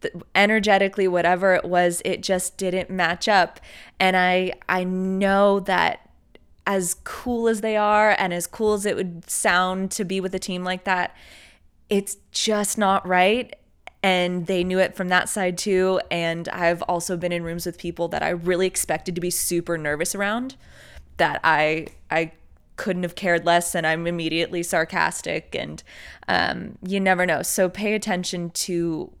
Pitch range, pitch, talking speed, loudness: 175-195 Hz, 185 Hz, 170 wpm, -22 LUFS